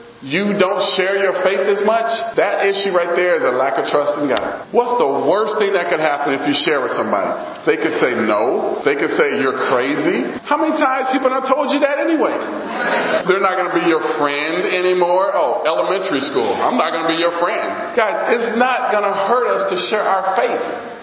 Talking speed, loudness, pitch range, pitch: 220 wpm, -17 LUFS, 180-265 Hz, 205 Hz